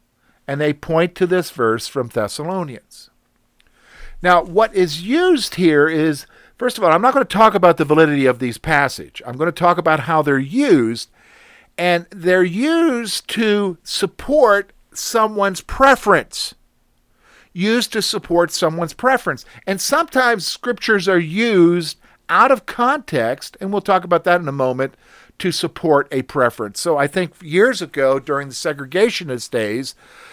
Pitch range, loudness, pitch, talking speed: 155-215 Hz, -17 LUFS, 175 Hz, 150 wpm